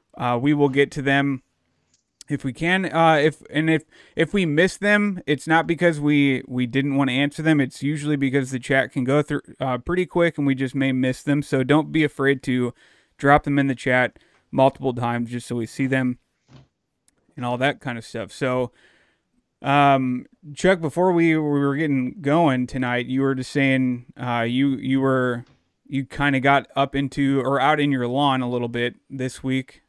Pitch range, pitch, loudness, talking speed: 130-150 Hz, 135 Hz, -21 LUFS, 200 wpm